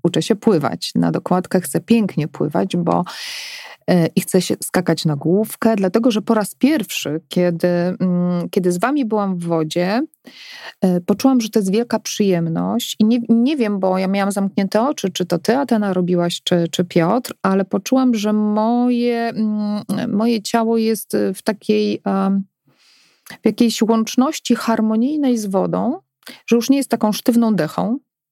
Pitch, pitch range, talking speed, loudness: 210 Hz, 180-230 Hz, 155 wpm, -18 LUFS